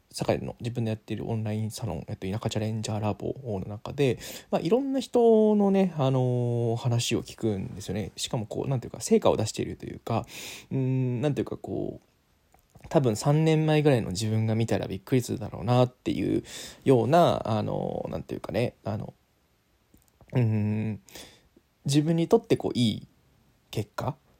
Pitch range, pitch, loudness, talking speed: 110-150 Hz, 120 Hz, -27 LUFS, 355 characters per minute